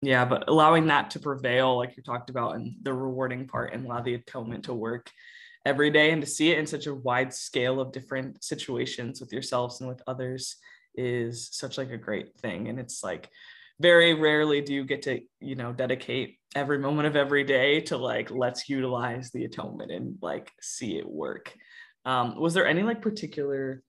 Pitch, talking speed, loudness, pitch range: 130 Hz, 200 wpm, -27 LUFS, 125-150 Hz